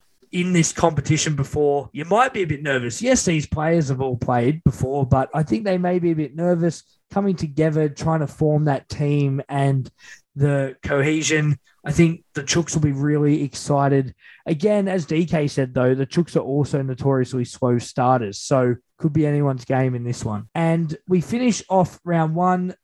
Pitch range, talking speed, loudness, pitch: 135-165 Hz, 185 wpm, -21 LUFS, 150 Hz